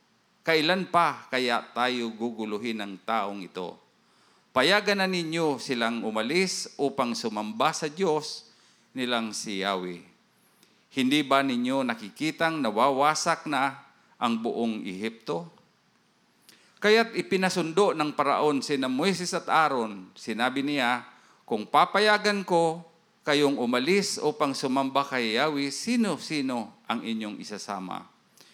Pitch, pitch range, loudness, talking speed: 140 Hz, 115-165 Hz, -26 LUFS, 110 wpm